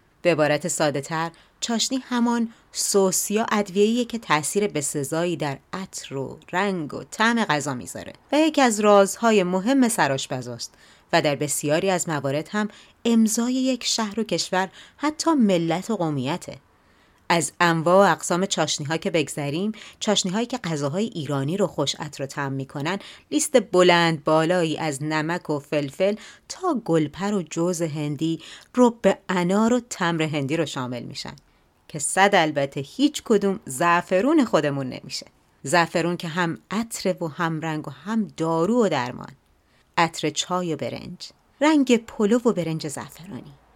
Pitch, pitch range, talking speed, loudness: 175 Hz, 150-210 Hz, 150 wpm, -23 LUFS